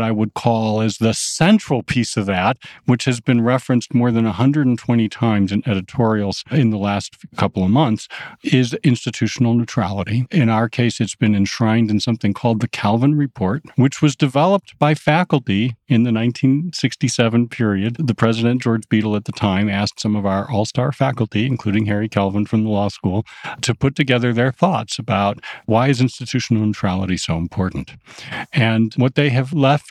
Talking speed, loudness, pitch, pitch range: 175 wpm, -18 LUFS, 115 Hz, 105-130 Hz